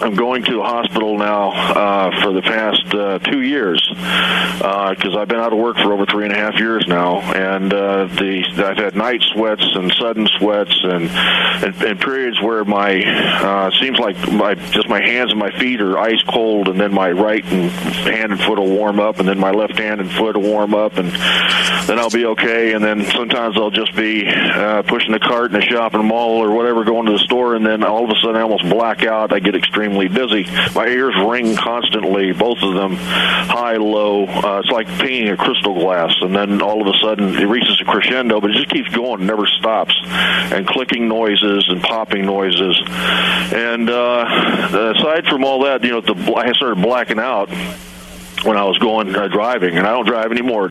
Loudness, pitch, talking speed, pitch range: -15 LUFS, 105 Hz, 210 wpm, 95-115 Hz